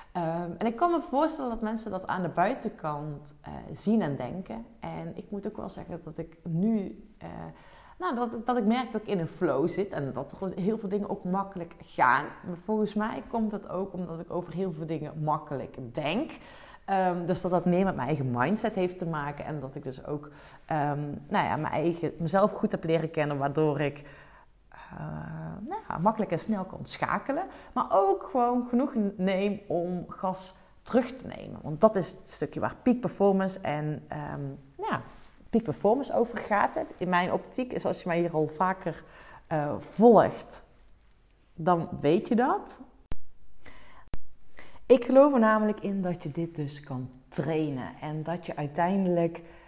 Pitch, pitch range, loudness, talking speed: 180 Hz, 155-215 Hz, -29 LUFS, 185 wpm